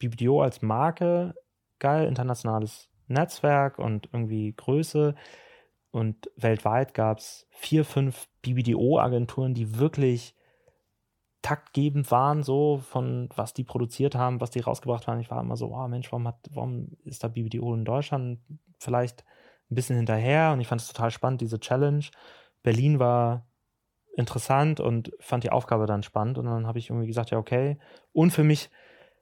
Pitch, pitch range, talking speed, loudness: 125 Hz, 115-140 Hz, 155 wpm, -27 LUFS